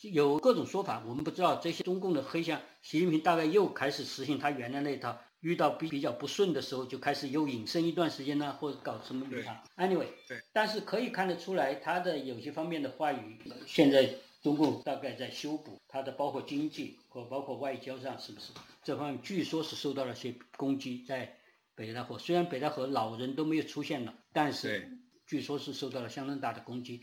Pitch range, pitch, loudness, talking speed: 130-165 Hz, 145 Hz, -34 LUFS, 335 characters per minute